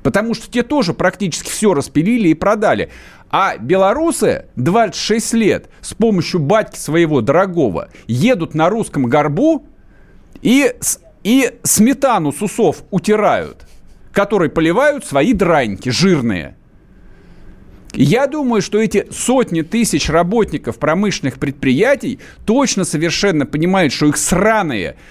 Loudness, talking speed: -15 LUFS, 110 wpm